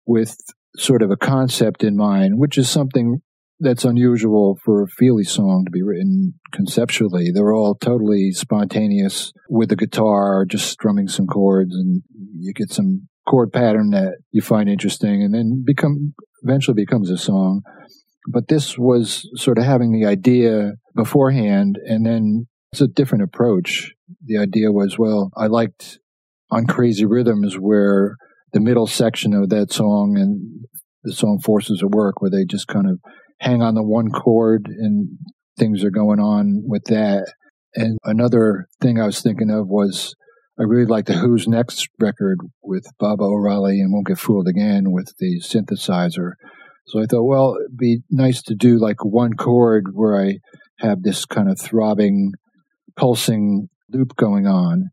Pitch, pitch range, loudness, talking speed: 115 Hz, 105-155 Hz, -17 LUFS, 165 wpm